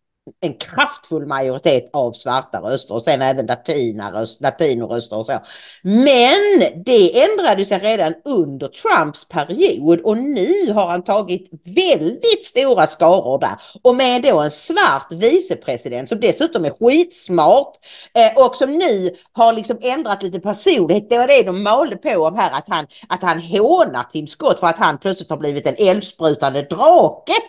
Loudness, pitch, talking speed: -16 LUFS, 215 Hz, 155 wpm